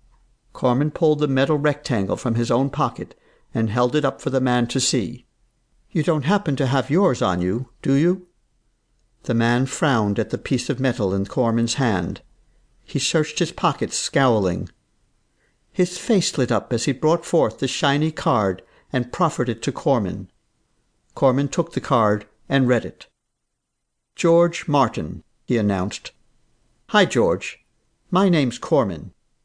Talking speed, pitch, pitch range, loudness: 155 wpm, 130 Hz, 120-150 Hz, -21 LUFS